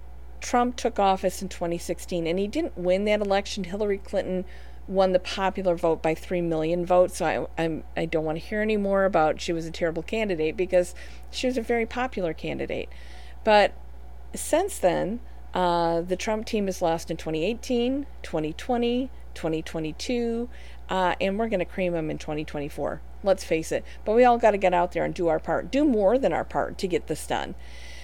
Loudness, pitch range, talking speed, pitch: -26 LUFS, 160-210 Hz, 195 wpm, 180 Hz